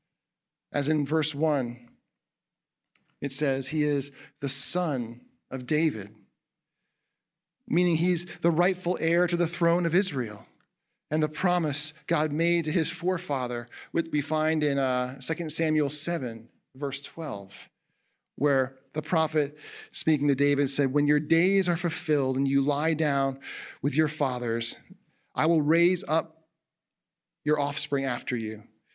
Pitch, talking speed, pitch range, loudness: 150 Hz, 140 wpm, 140-165 Hz, -26 LUFS